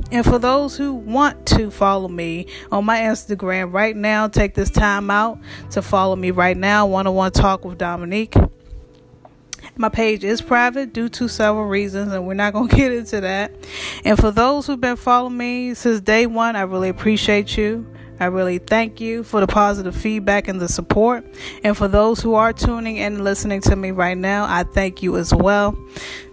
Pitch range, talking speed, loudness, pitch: 190-230 Hz, 200 wpm, -18 LUFS, 210 Hz